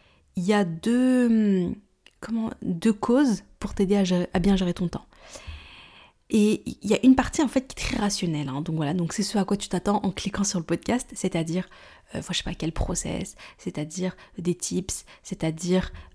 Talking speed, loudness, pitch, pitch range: 200 wpm, -25 LUFS, 190 Hz, 175-215 Hz